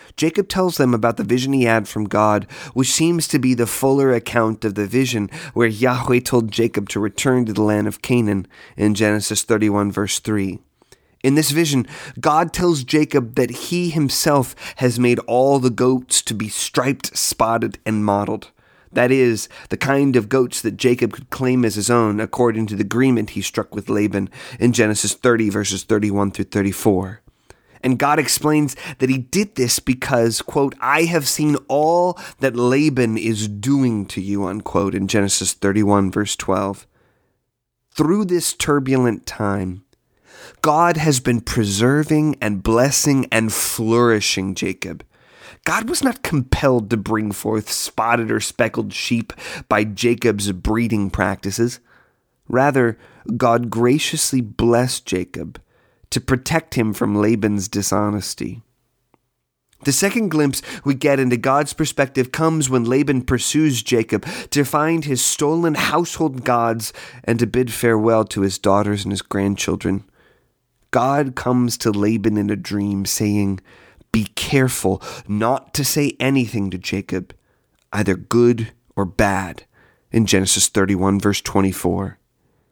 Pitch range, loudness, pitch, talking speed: 105-135 Hz, -18 LUFS, 120 Hz, 145 wpm